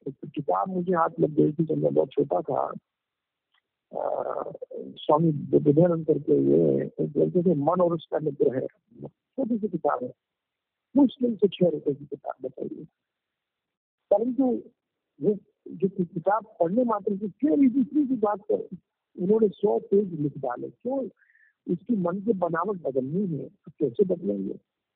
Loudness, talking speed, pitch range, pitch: -26 LUFS, 135 wpm, 160-230 Hz, 190 Hz